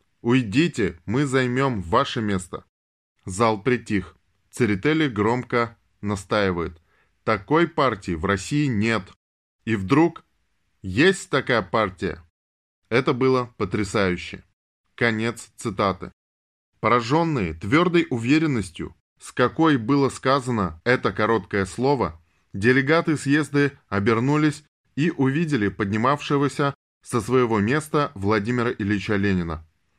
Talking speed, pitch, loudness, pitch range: 95 wpm, 115 Hz, -22 LUFS, 100-140 Hz